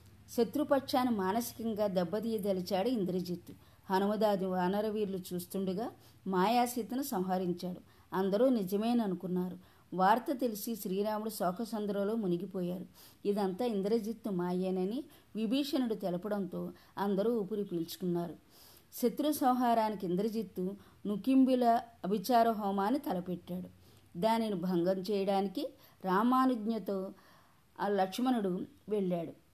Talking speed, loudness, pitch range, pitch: 75 wpm, -33 LUFS, 185-230 Hz, 205 Hz